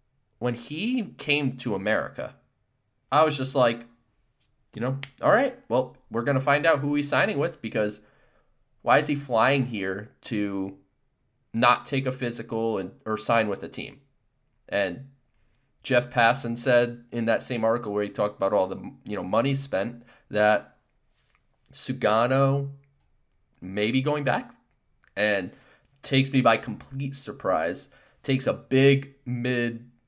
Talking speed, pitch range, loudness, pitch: 145 wpm, 115-135 Hz, -25 LUFS, 125 Hz